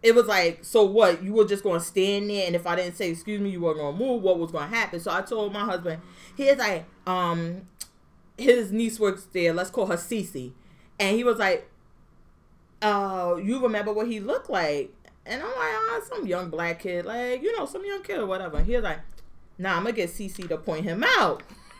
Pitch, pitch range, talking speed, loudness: 200 Hz, 175-230 Hz, 230 wpm, -26 LUFS